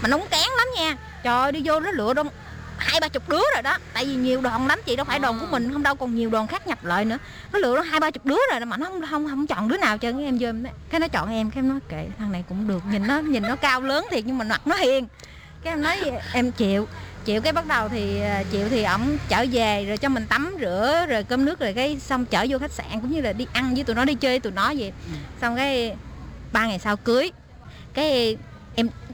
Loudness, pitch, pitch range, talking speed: -23 LUFS, 255 Hz, 225-295 Hz, 280 wpm